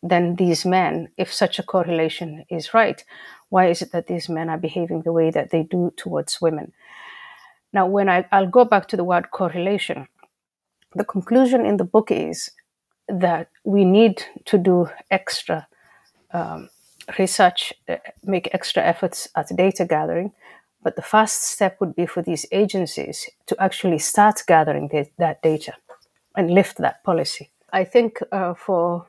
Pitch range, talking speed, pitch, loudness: 170-200 Hz, 165 wpm, 185 Hz, -20 LUFS